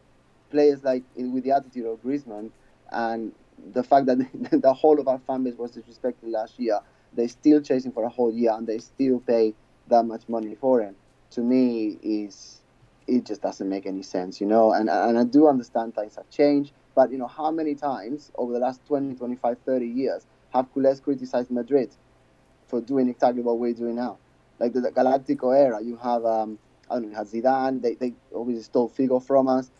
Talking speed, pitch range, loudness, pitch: 205 wpm, 115-130 Hz, -24 LUFS, 125 Hz